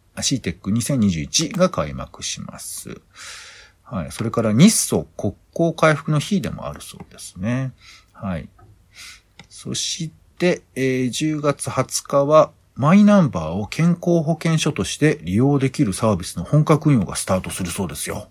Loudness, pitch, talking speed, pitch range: -20 LUFS, 140 Hz, 275 characters per minute, 100-160 Hz